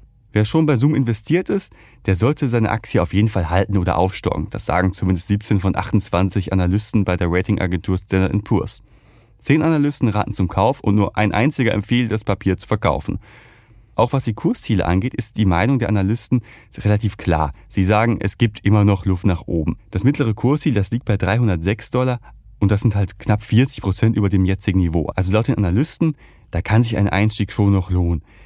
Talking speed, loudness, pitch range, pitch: 200 wpm, -19 LUFS, 95-115 Hz, 105 Hz